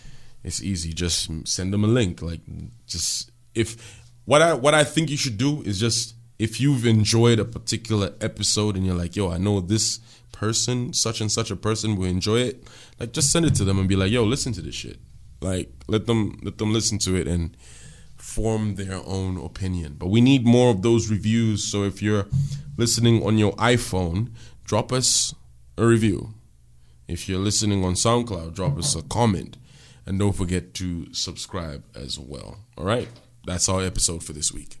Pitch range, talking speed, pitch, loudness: 95-120 Hz, 190 wpm, 110 Hz, -23 LUFS